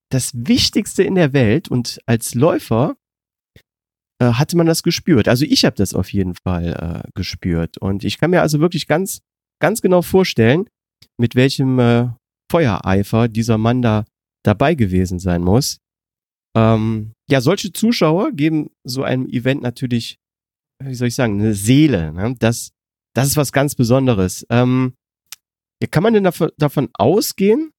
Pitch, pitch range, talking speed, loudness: 125 Hz, 110-155 Hz, 160 wpm, -17 LUFS